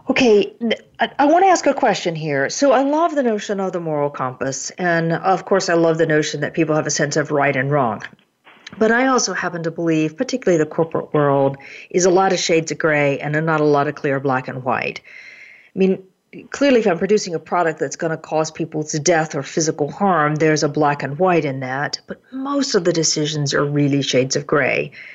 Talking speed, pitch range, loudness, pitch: 225 wpm, 150-195 Hz, -18 LUFS, 165 Hz